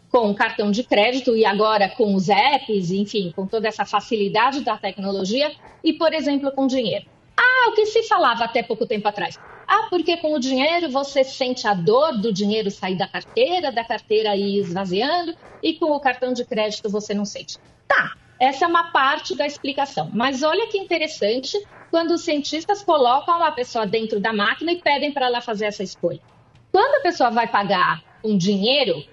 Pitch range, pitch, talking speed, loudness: 210-315 Hz, 250 Hz, 190 wpm, -20 LUFS